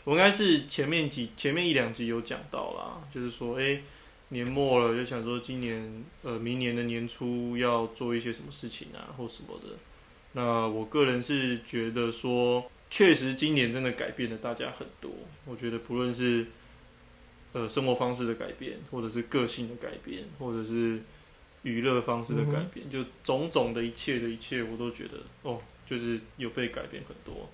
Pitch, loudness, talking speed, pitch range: 120 Hz, -30 LUFS, 270 characters per minute, 115-125 Hz